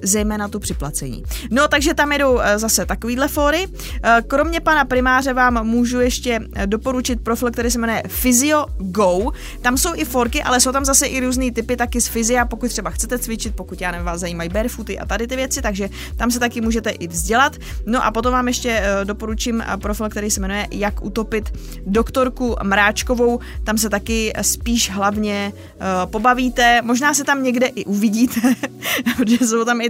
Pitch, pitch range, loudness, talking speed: 235 Hz, 215-255 Hz, -18 LUFS, 175 wpm